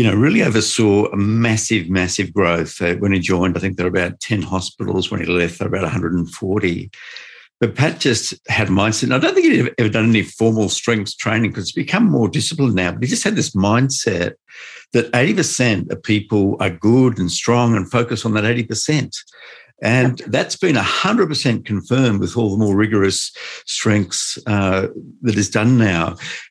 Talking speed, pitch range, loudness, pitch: 185 wpm, 95-120 Hz, -17 LUFS, 110 Hz